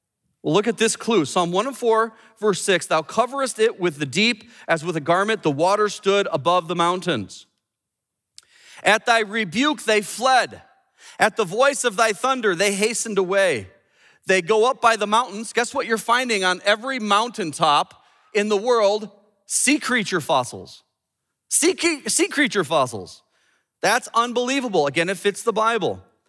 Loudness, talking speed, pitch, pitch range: -20 LUFS, 155 wpm, 220 Hz, 195-240 Hz